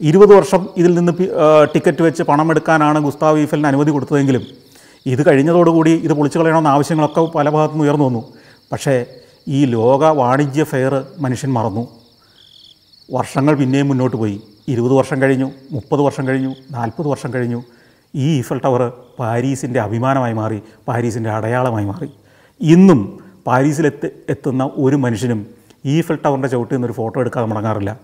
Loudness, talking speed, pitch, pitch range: -15 LUFS, 135 wpm, 135 Hz, 120-150 Hz